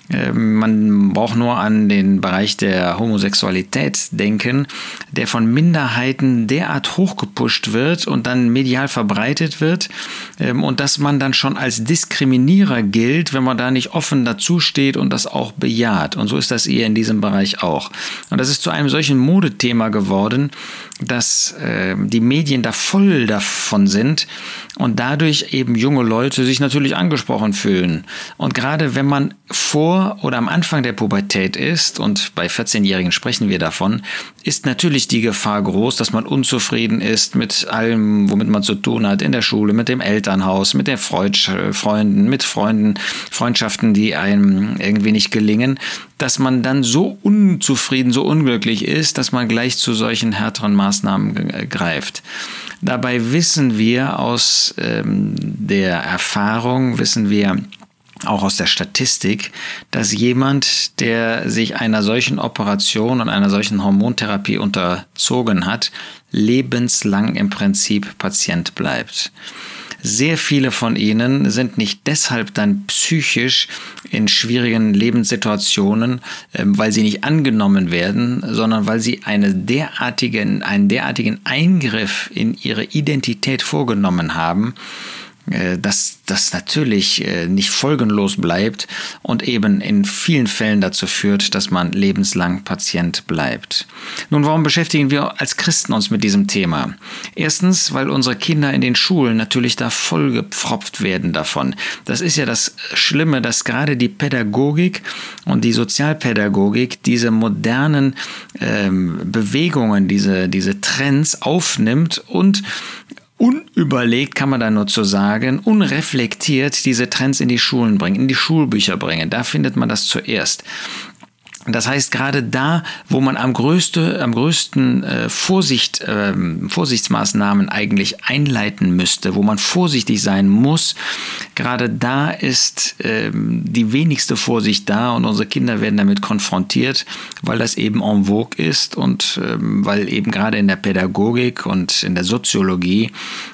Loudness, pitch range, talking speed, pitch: -15 LUFS, 105-155 Hz, 140 wpm, 125 Hz